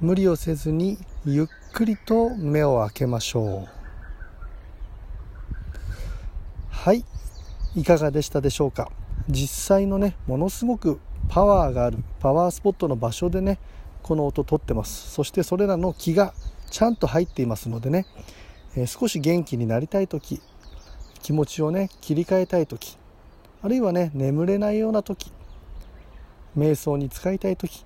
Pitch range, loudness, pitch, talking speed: 115-185 Hz, -24 LUFS, 150 Hz, 290 characters per minute